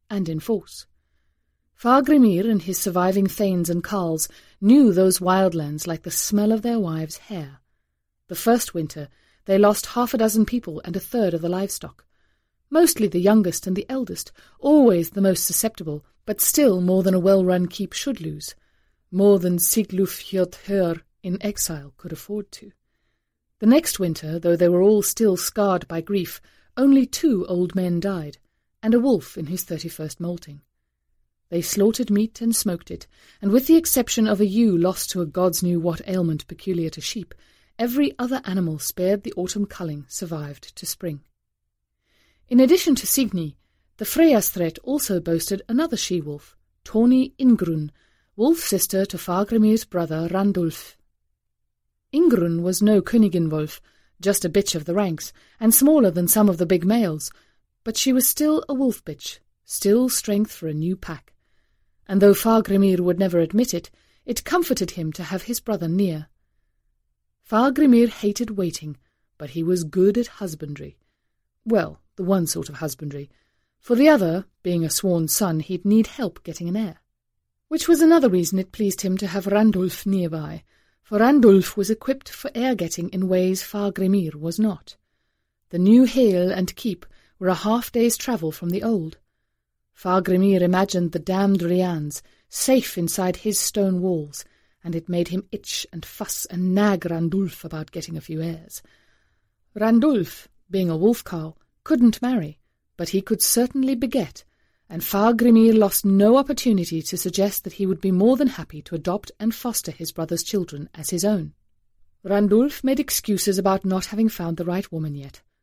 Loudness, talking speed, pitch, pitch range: -21 LUFS, 170 wpm, 190 Hz, 170-220 Hz